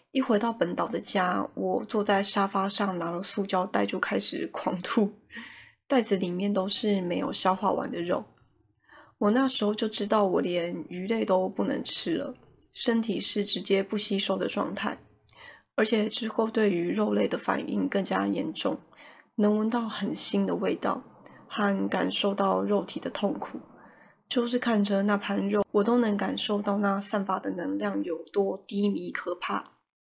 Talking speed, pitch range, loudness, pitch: 240 characters per minute, 190-220 Hz, -28 LUFS, 205 Hz